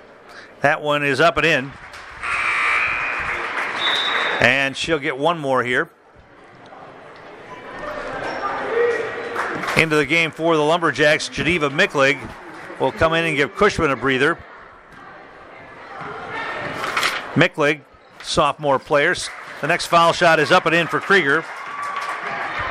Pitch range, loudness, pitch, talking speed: 135-170 Hz, -19 LUFS, 160 Hz, 110 wpm